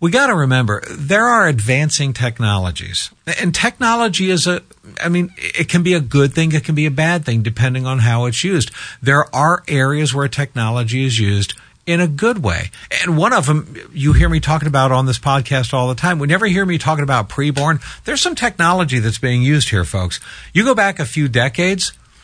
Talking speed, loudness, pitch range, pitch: 210 wpm, -16 LUFS, 130-175 Hz, 145 Hz